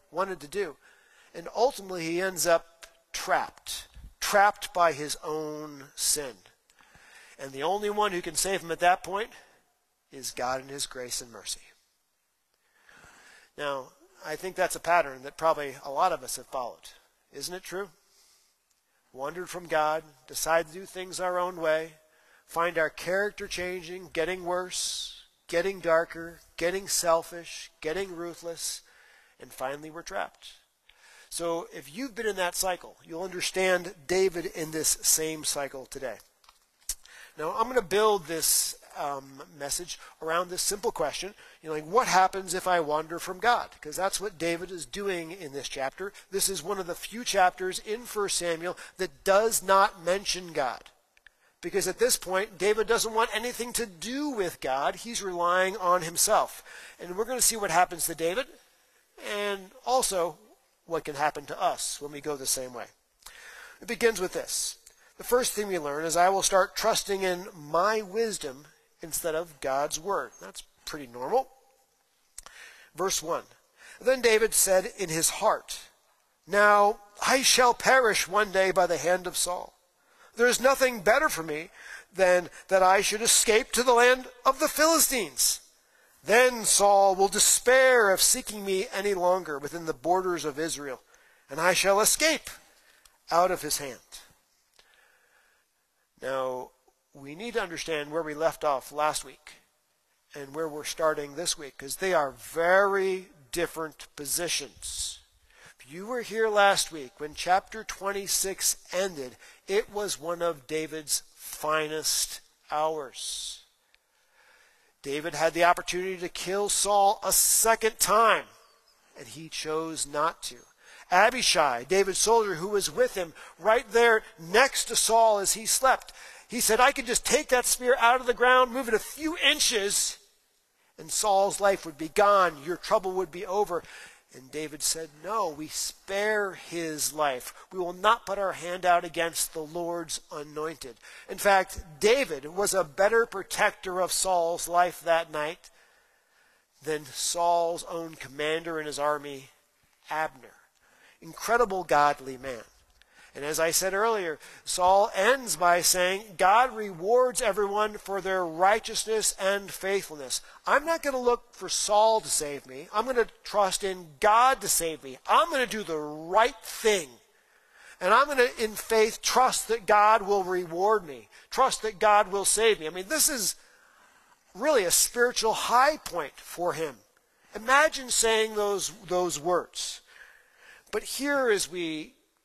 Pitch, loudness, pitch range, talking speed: 185 Hz, -26 LUFS, 160-215 Hz, 155 wpm